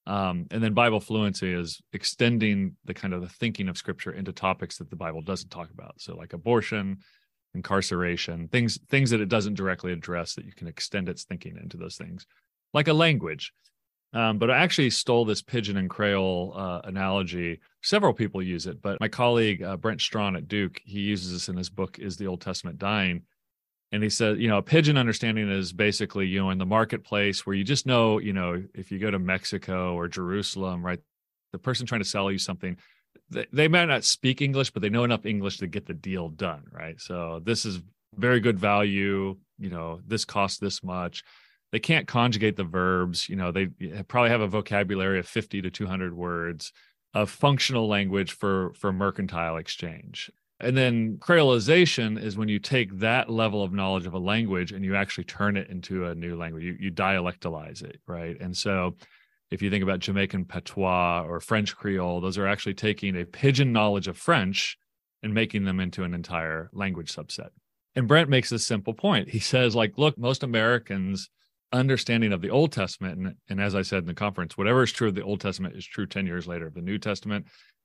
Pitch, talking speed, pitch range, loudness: 100 Hz, 205 wpm, 90-110 Hz, -26 LUFS